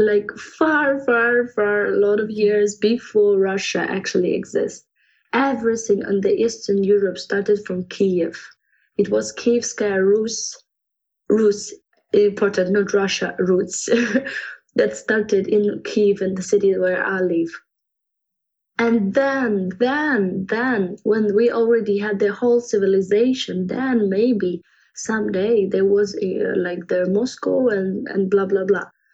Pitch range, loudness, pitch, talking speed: 195-230 Hz, -20 LUFS, 205 Hz, 130 wpm